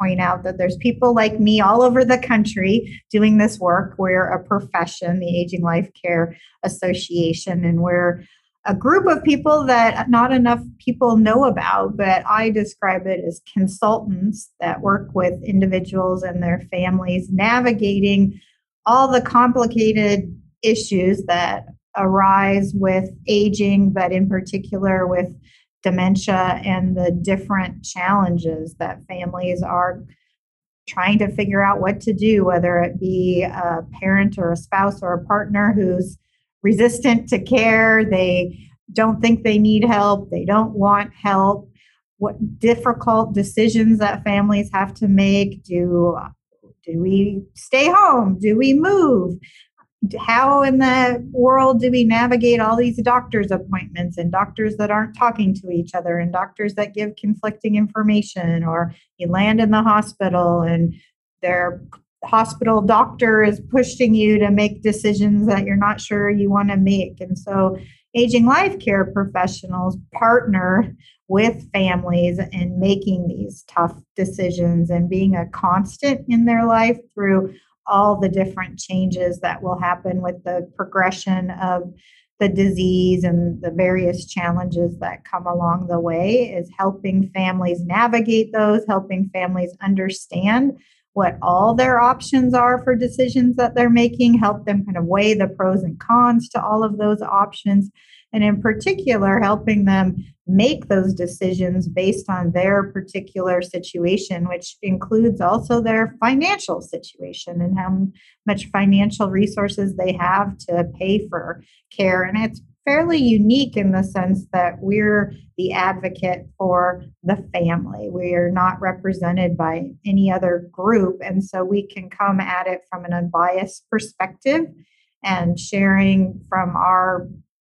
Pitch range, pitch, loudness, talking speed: 180-215 Hz, 195 Hz, -18 LUFS, 145 wpm